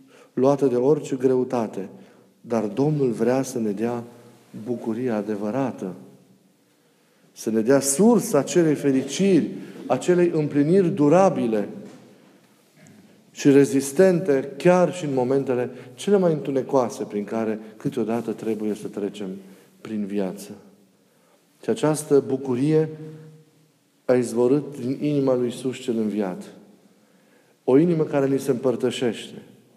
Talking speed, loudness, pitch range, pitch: 110 wpm, -22 LUFS, 115-145 Hz, 130 Hz